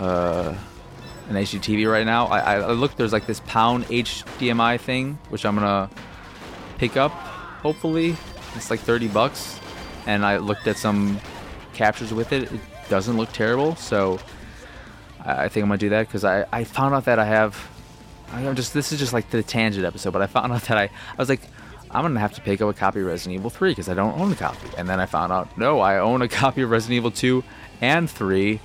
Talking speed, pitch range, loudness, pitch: 220 wpm, 100-125 Hz, -22 LUFS, 110 Hz